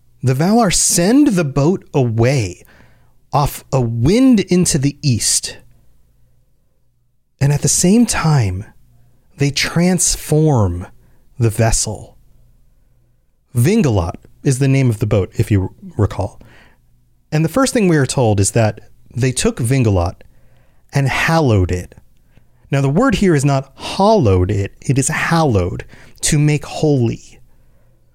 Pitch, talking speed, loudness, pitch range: 130 Hz, 130 wpm, -15 LUFS, 105-155 Hz